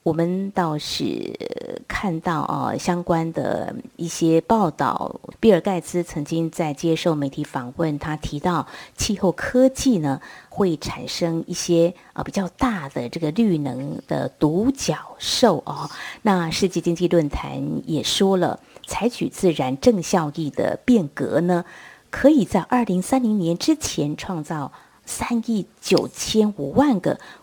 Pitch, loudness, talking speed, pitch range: 175 Hz, -22 LUFS, 205 characters per minute, 160-210 Hz